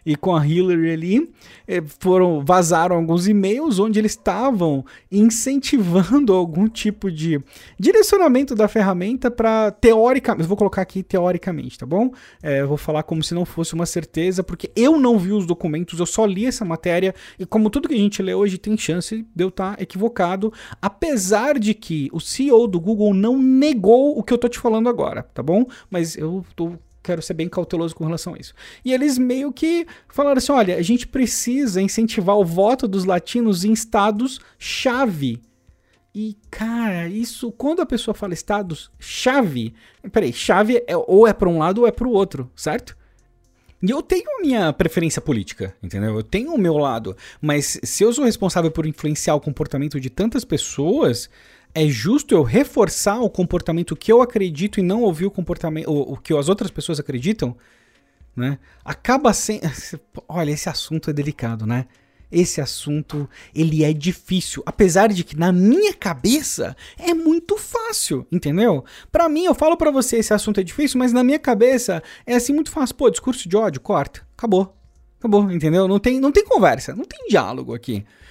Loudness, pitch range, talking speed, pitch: -19 LUFS, 165-235 Hz, 180 wpm, 195 Hz